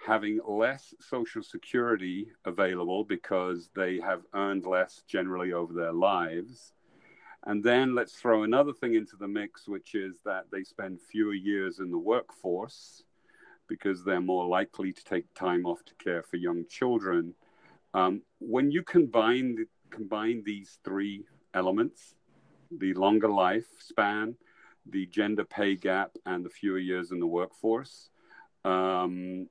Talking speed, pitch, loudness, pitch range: 140 wpm, 95 Hz, -30 LUFS, 90-110 Hz